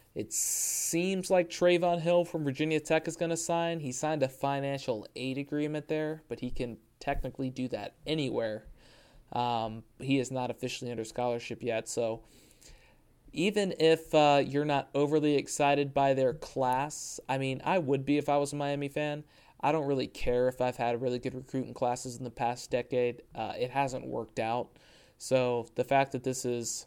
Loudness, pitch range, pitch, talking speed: -31 LUFS, 125-150 Hz, 135 Hz, 185 wpm